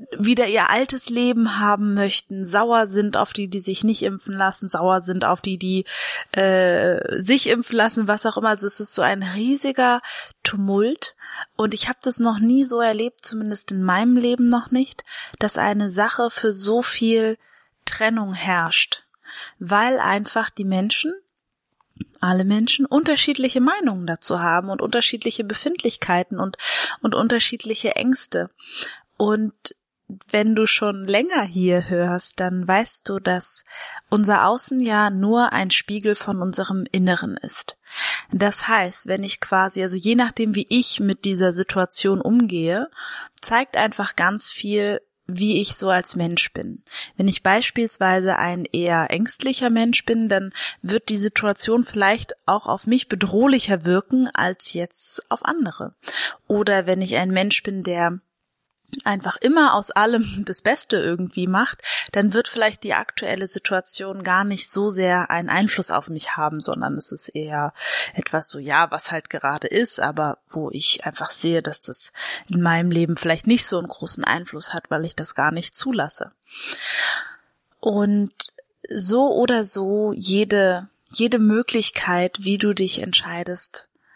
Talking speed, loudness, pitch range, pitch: 155 wpm, -19 LUFS, 190-230 Hz, 205 Hz